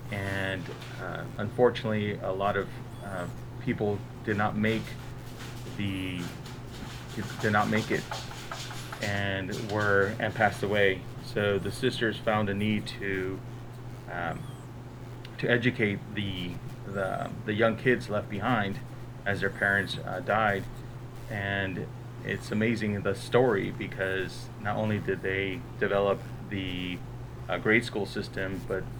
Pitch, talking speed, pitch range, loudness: 115 Hz, 125 wpm, 100-125 Hz, -30 LUFS